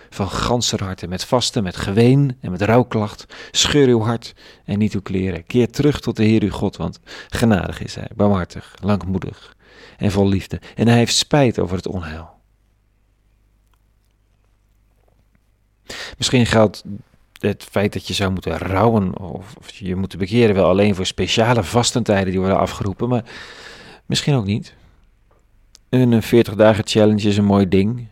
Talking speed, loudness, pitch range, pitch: 155 wpm, -18 LUFS, 95-115 Hz, 105 Hz